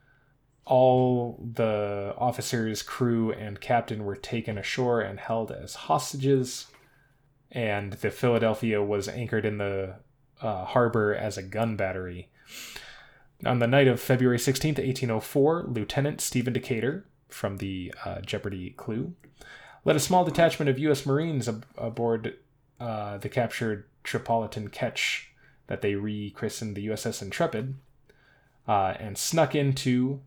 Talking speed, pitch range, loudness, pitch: 130 wpm, 105-135 Hz, -28 LUFS, 120 Hz